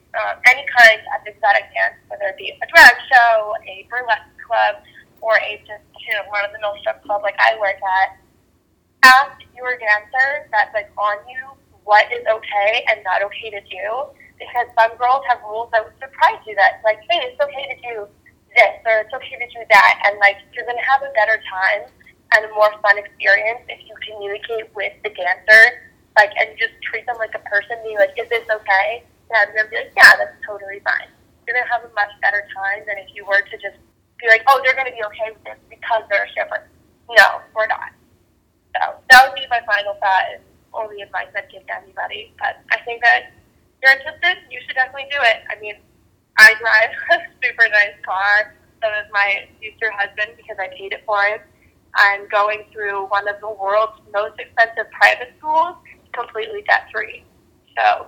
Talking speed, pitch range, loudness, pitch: 205 wpm, 205-250 Hz, -16 LUFS, 220 Hz